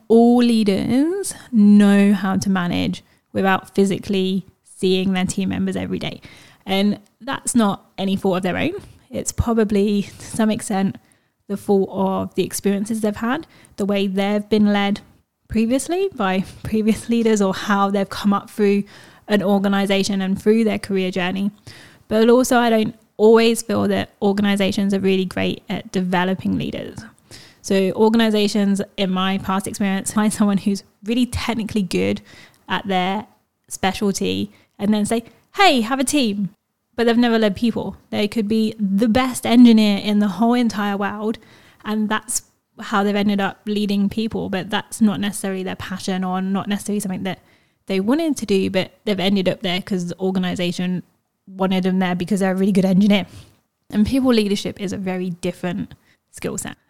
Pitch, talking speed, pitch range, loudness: 200 Hz, 165 wpm, 190-220 Hz, -19 LUFS